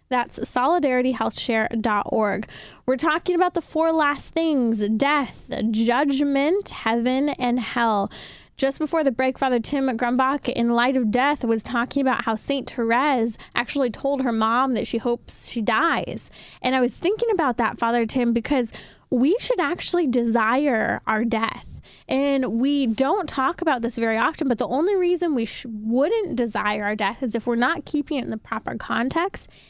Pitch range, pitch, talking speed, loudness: 235-285 Hz, 255 Hz, 170 wpm, -22 LUFS